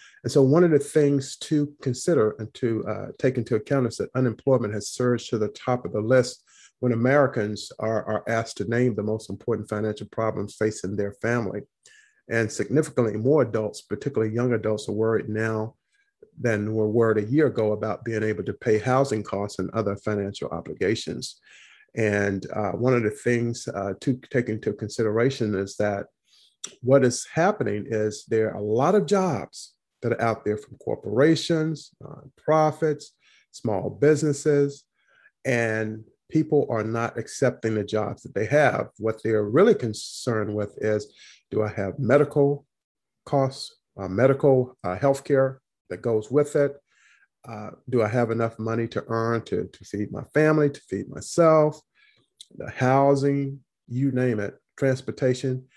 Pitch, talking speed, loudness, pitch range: 115 Hz, 160 wpm, -24 LUFS, 110-135 Hz